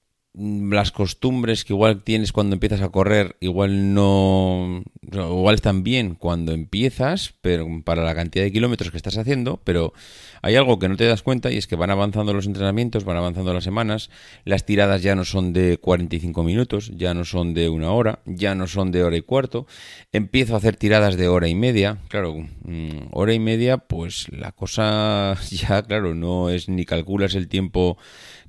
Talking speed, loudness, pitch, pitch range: 185 wpm, -21 LUFS, 100 Hz, 90-105 Hz